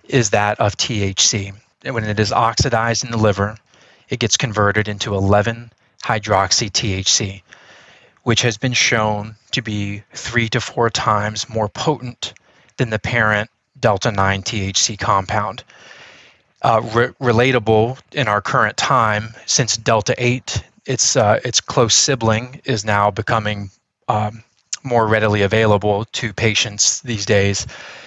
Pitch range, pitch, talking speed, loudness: 105-120 Hz, 110 Hz, 125 wpm, -17 LUFS